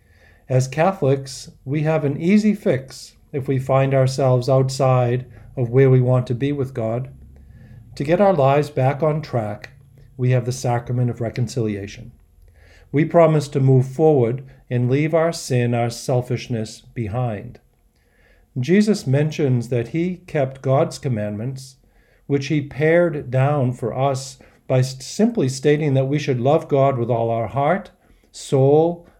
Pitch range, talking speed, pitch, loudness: 120-145 Hz, 145 wpm, 130 Hz, -20 LUFS